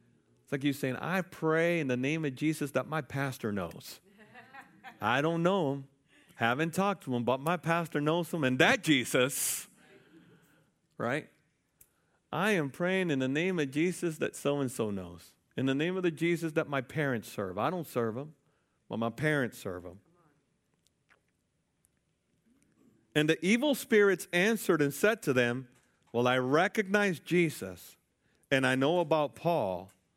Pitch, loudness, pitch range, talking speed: 145 Hz, -30 LUFS, 125-170 Hz, 160 wpm